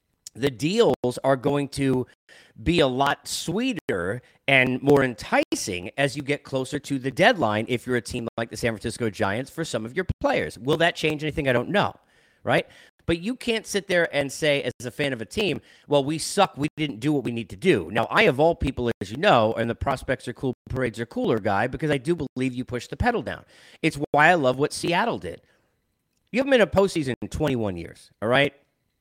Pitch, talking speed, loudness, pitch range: 140 Hz, 225 wpm, -24 LUFS, 120-155 Hz